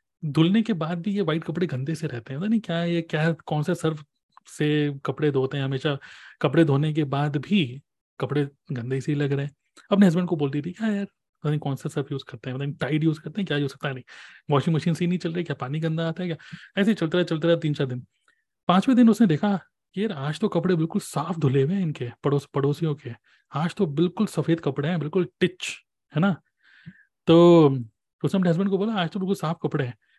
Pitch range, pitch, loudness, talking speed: 145-180 Hz, 160 Hz, -24 LUFS, 245 wpm